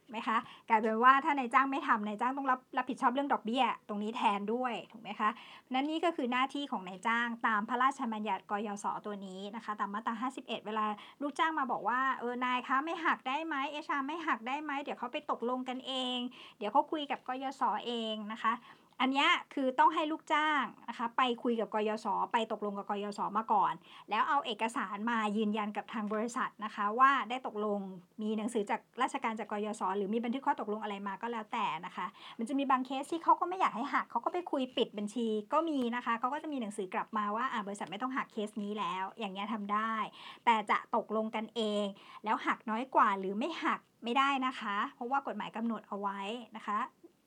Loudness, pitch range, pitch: -34 LUFS, 215-265 Hz, 235 Hz